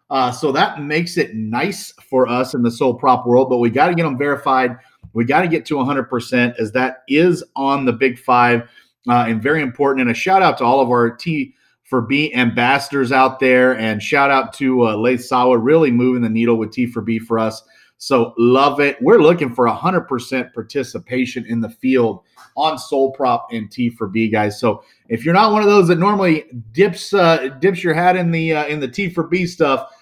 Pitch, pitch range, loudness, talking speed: 130 Hz, 120-155 Hz, -16 LUFS, 220 wpm